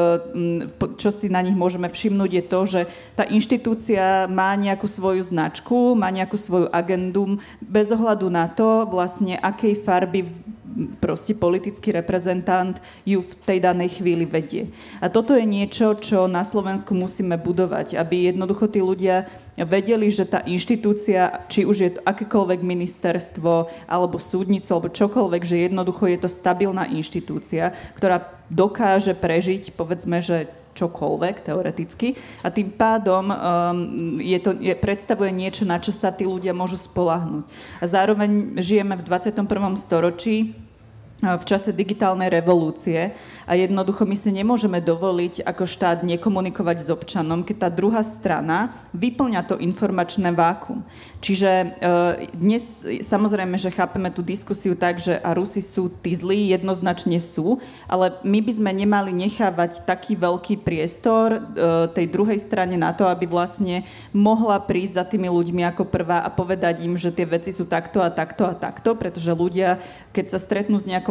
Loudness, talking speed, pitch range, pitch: -21 LUFS, 150 wpm, 175-205 Hz, 185 Hz